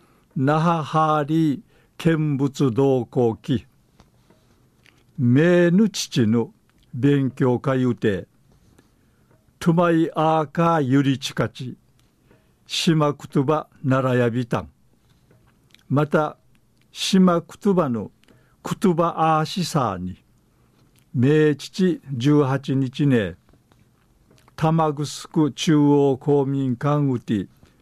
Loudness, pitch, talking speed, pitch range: -21 LUFS, 145 Hz, 150 characters per minute, 125-160 Hz